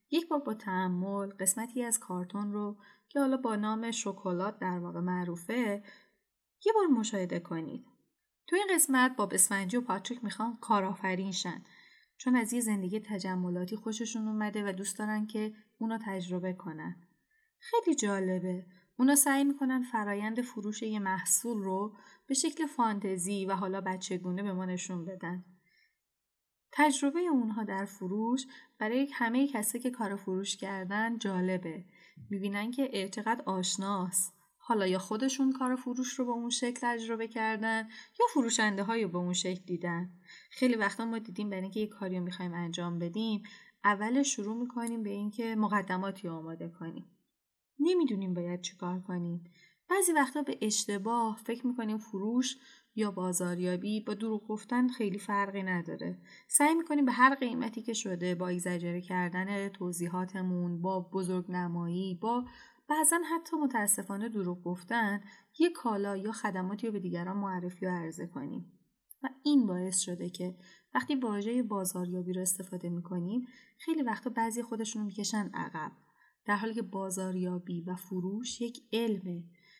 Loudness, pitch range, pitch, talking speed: -33 LUFS, 185-235 Hz, 205 Hz, 145 wpm